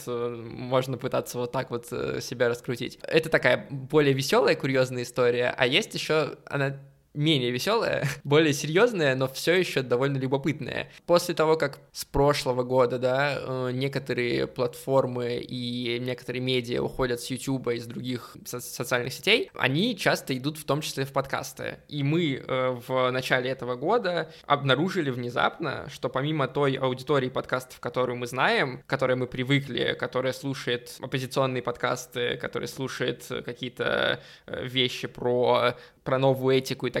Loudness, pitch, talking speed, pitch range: -27 LUFS, 130 Hz, 145 wpm, 125-140 Hz